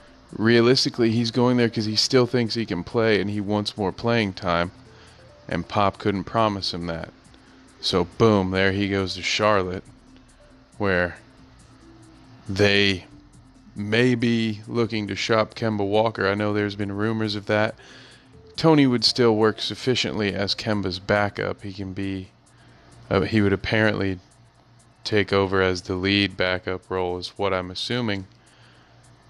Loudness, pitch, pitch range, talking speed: -22 LUFS, 105 Hz, 95-115 Hz, 145 wpm